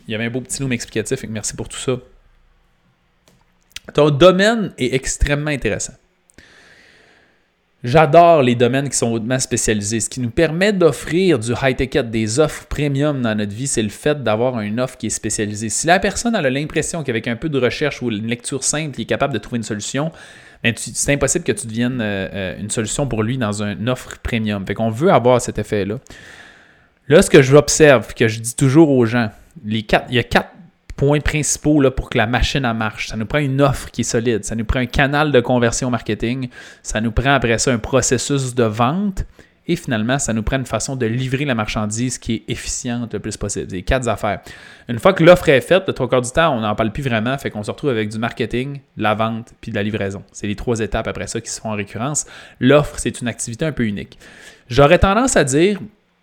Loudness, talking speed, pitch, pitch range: -17 LUFS, 225 wpm, 120 Hz, 110-140 Hz